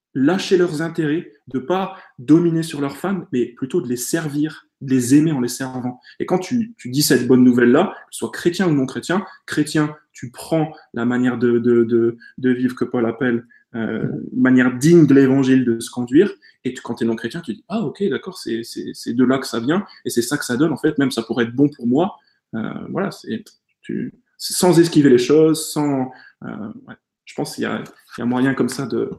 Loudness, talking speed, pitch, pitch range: -19 LUFS, 230 wpm, 140 Hz, 125-165 Hz